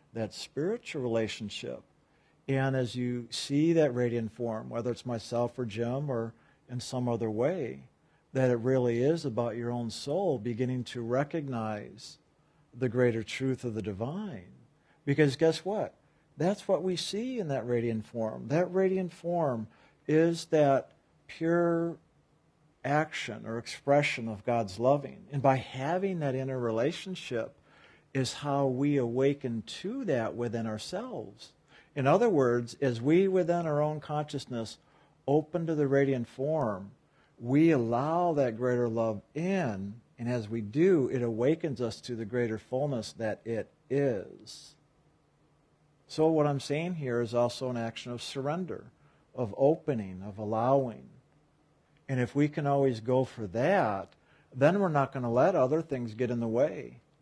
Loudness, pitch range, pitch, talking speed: -30 LUFS, 120-155 Hz, 135 Hz, 150 wpm